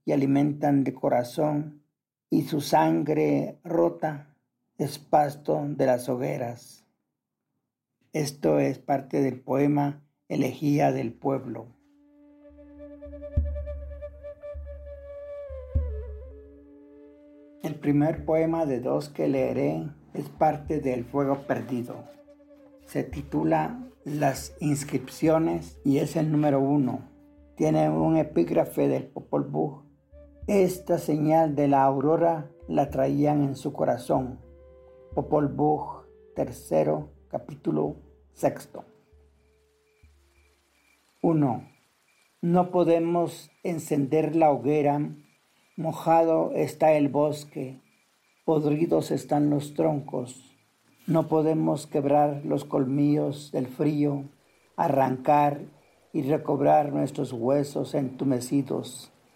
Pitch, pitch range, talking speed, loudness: 145 Hz, 125-155 Hz, 90 wpm, -26 LUFS